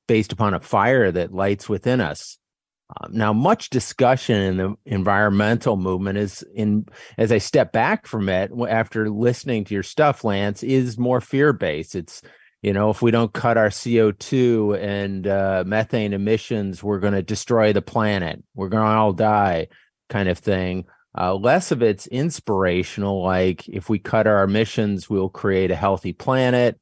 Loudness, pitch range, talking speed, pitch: -21 LUFS, 95-115 Hz, 170 wpm, 105 Hz